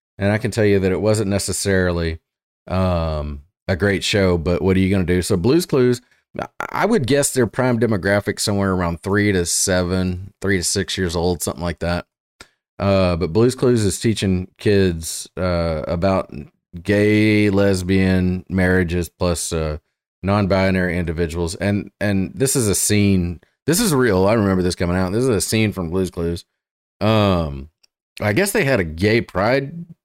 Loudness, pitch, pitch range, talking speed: -19 LUFS, 95 Hz, 90-105 Hz, 175 wpm